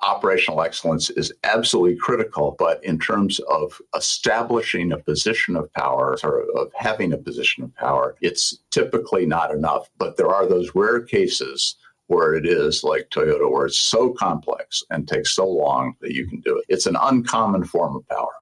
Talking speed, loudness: 180 wpm, -20 LUFS